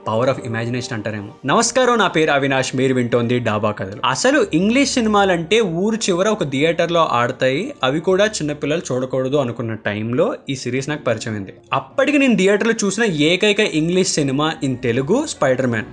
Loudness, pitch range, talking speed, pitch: -18 LUFS, 125-200 Hz, 175 wpm, 150 Hz